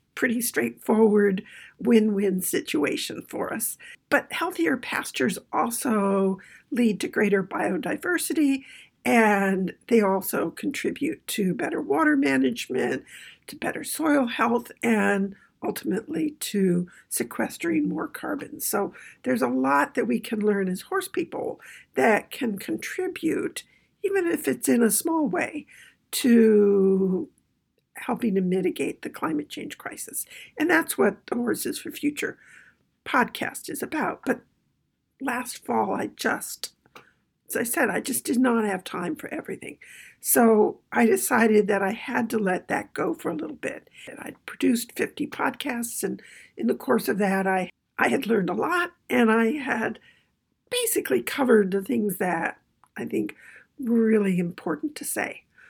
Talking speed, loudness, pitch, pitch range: 145 wpm, -25 LUFS, 235 Hz, 200-305 Hz